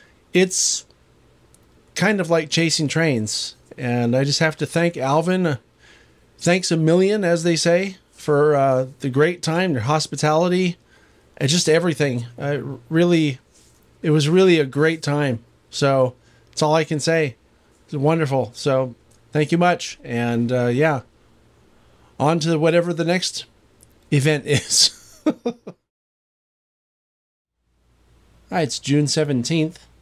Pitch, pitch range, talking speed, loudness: 155 Hz, 130-170 Hz, 125 wpm, -20 LUFS